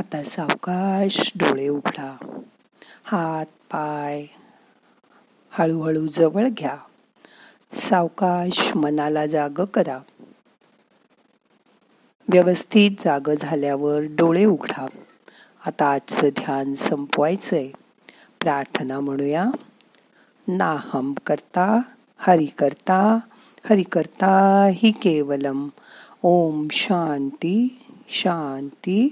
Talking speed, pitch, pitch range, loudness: 70 wpm, 170 Hz, 150-200 Hz, -21 LUFS